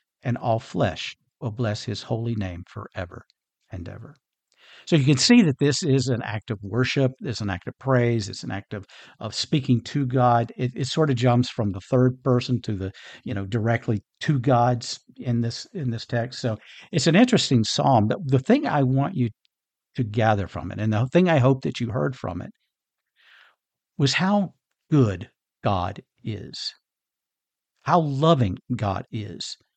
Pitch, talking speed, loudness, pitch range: 125 Hz, 180 wpm, -23 LUFS, 110-135 Hz